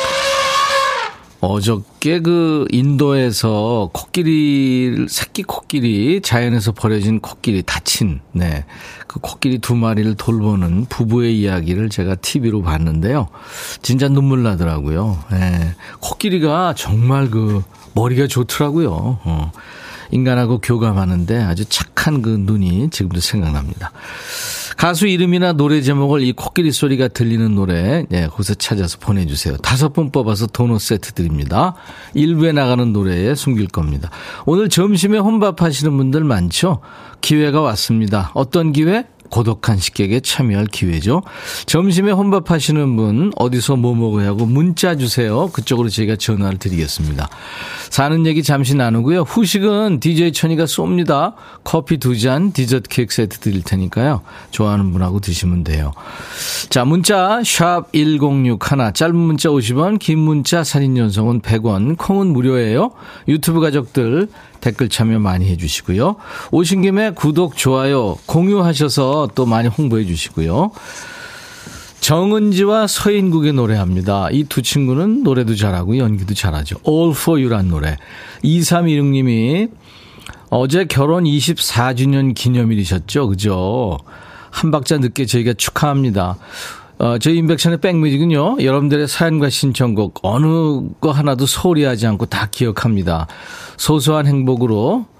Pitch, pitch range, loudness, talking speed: 130 Hz, 105-160 Hz, -16 LUFS, 300 characters per minute